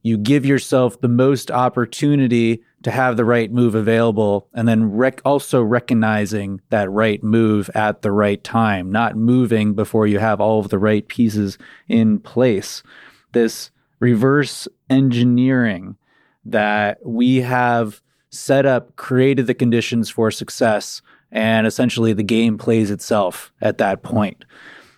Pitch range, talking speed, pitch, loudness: 110-125 Hz, 140 wpm, 115 Hz, -17 LUFS